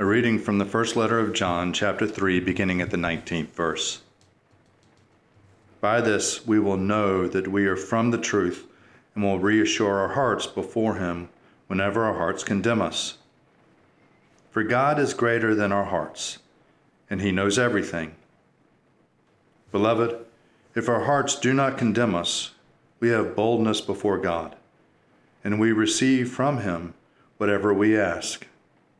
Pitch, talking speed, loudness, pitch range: 105 Hz, 145 wpm, -24 LUFS, 95-115 Hz